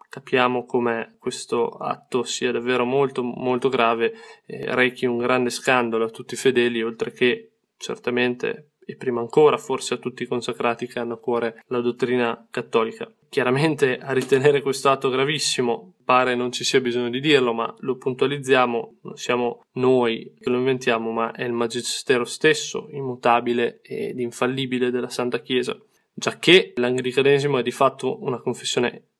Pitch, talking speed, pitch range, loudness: 125 Hz, 160 wpm, 120-130 Hz, -22 LUFS